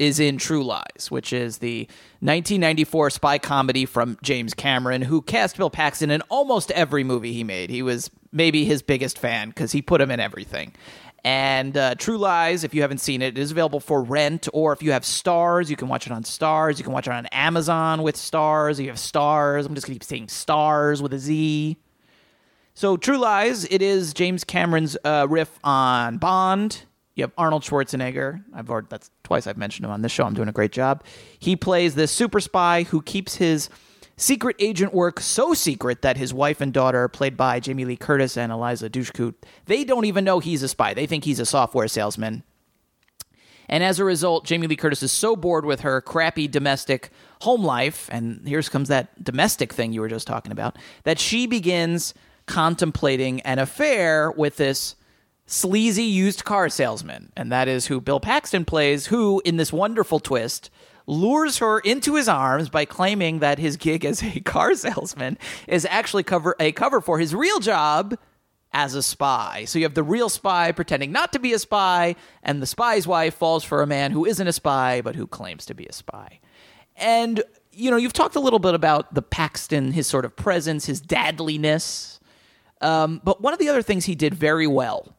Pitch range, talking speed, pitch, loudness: 135-180 Hz, 200 wpm, 155 Hz, -22 LUFS